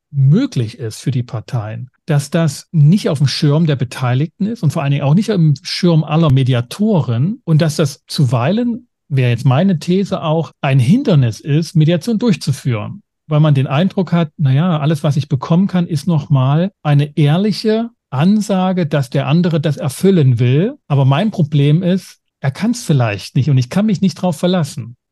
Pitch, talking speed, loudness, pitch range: 155 Hz, 185 wpm, -15 LUFS, 140-180 Hz